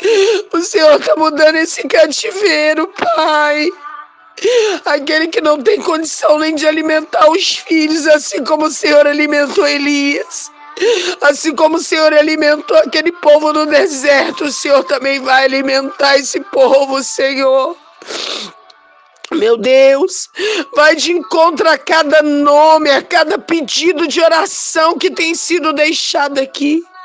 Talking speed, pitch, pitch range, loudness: 130 wpm, 310 Hz, 290-335 Hz, -11 LUFS